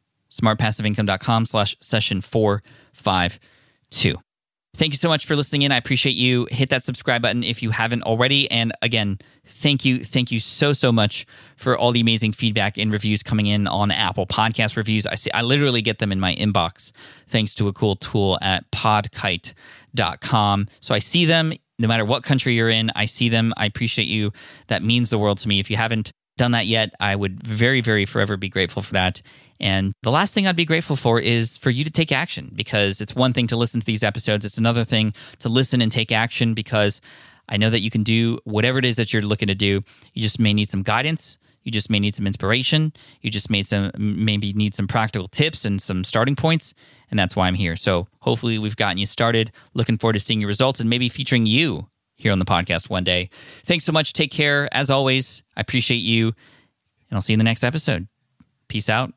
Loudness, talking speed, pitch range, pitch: -20 LUFS, 220 wpm, 105-125 Hz, 115 Hz